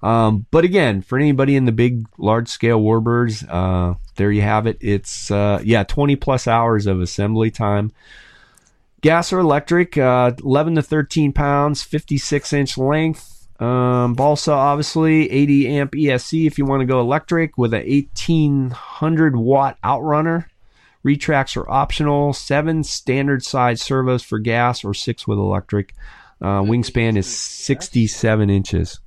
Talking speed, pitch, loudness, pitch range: 145 wpm, 125 Hz, -18 LUFS, 110-145 Hz